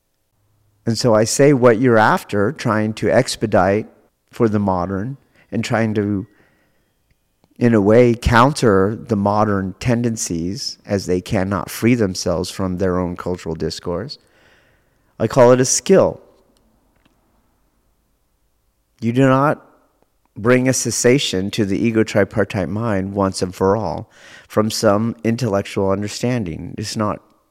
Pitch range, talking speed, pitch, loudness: 95-120 Hz, 130 wpm, 105 Hz, -17 LUFS